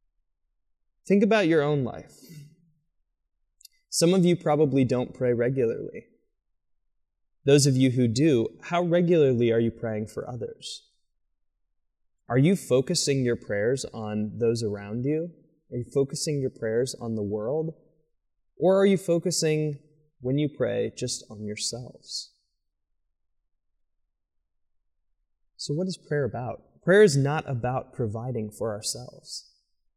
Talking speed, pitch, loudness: 125 wpm, 125 Hz, -25 LUFS